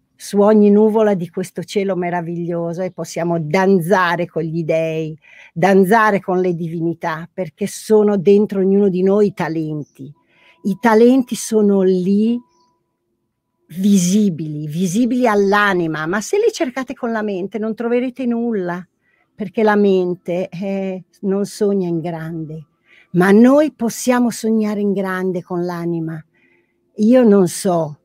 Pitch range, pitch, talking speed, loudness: 170-215 Hz, 195 Hz, 130 wpm, -16 LUFS